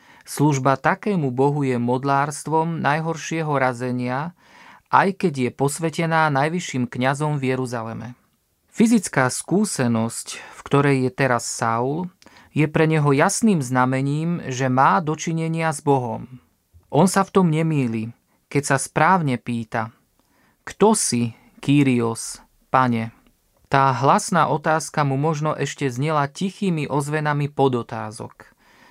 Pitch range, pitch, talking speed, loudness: 125-160 Hz, 140 Hz, 115 wpm, -21 LUFS